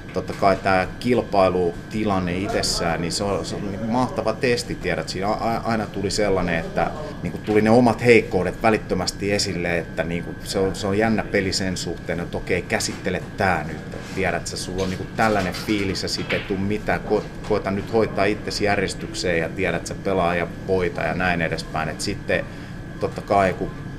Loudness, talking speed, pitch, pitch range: -22 LUFS, 190 wpm, 100 Hz, 95-110 Hz